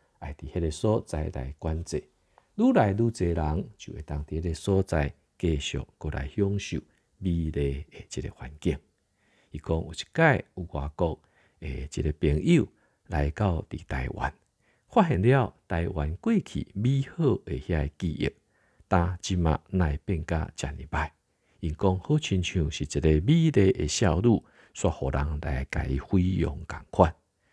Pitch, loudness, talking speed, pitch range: 80 Hz, -28 LUFS, 215 characters per minute, 75-95 Hz